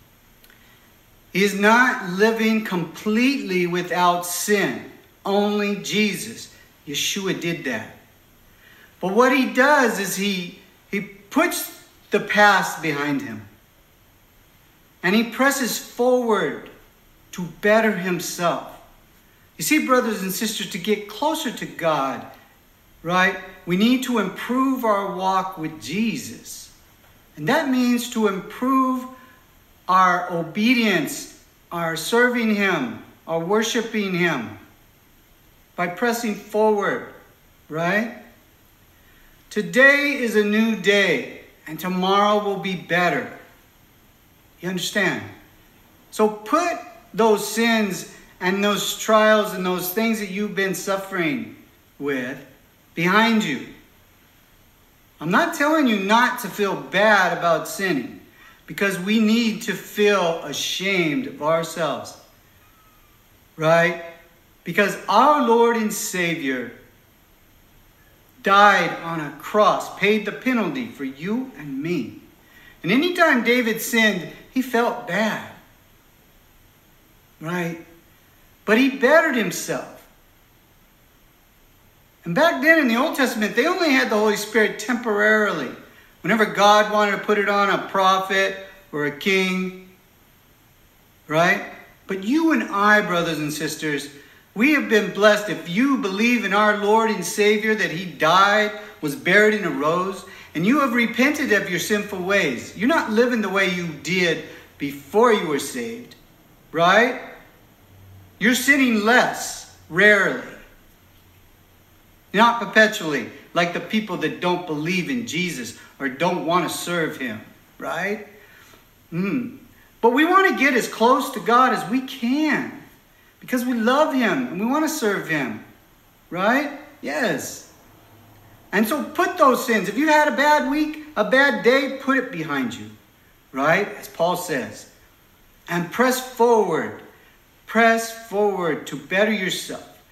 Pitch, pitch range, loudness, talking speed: 200 Hz, 165-230 Hz, -20 LUFS, 125 wpm